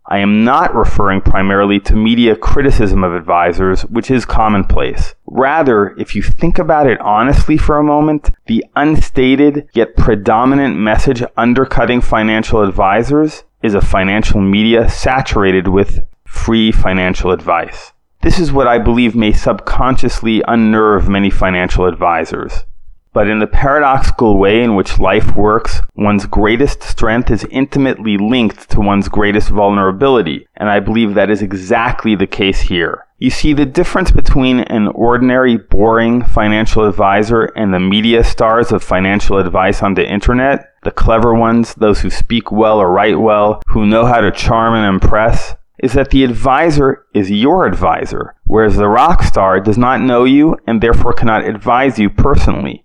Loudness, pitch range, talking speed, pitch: -12 LUFS, 100-120 Hz, 155 wpm, 110 Hz